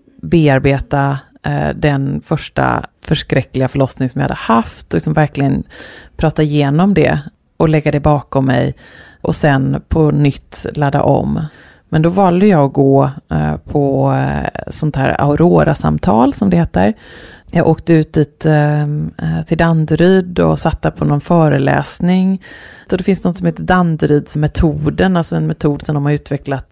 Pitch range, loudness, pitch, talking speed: 140-165 Hz, -14 LUFS, 150 Hz, 140 wpm